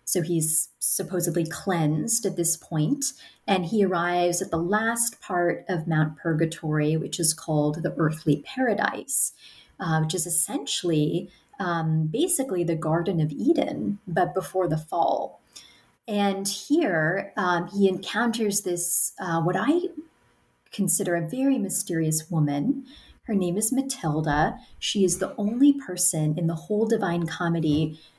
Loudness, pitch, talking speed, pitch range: -24 LUFS, 180 Hz, 140 wpm, 160-205 Hz